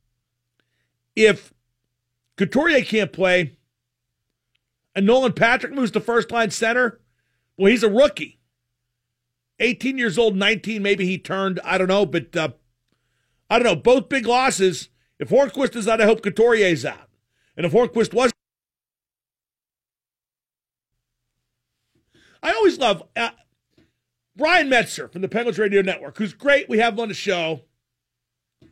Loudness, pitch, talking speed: -20 LUFS, 195 Hz, 135 wpm